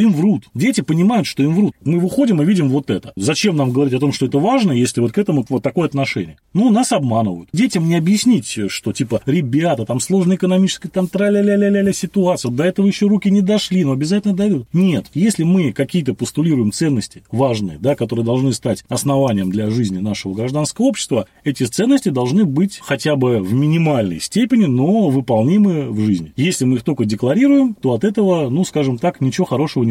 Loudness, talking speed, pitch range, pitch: -16 LUFS, 200 wpm, 125-195 Hz, 150 Hz